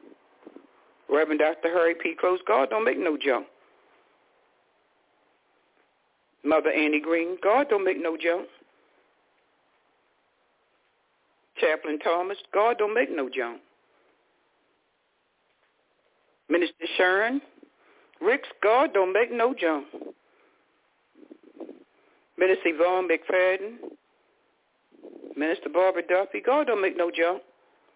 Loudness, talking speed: -25 LUFS, 95 wpm